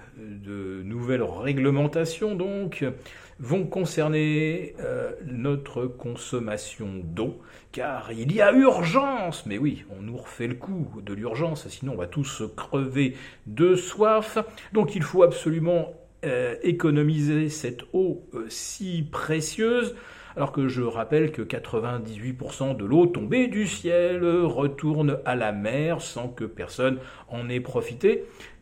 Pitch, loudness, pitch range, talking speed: 145 Hz, -26 LUFS, 120-175 Hz, 130 wpm